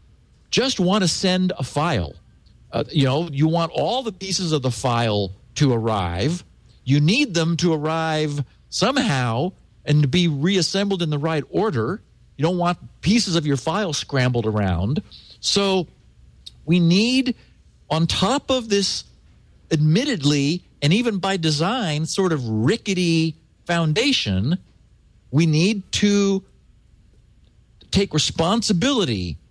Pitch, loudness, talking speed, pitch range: 160 Hz, -21 LUFS, 130 wpm, 140-190 Hz